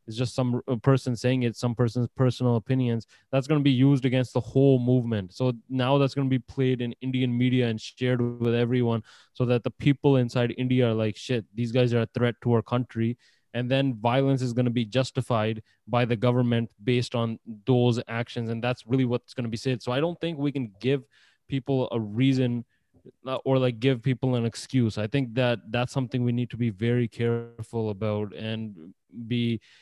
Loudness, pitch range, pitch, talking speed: -26 LUFS, 115-130 Hz, 125 Hz, 205 wpm